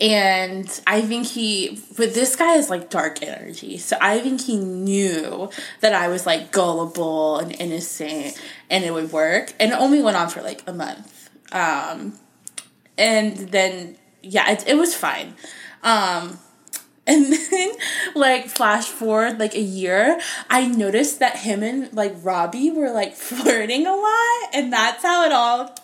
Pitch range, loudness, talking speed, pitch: 190-260 Hz, -20 LUFS, 165 wpm, 215 Hz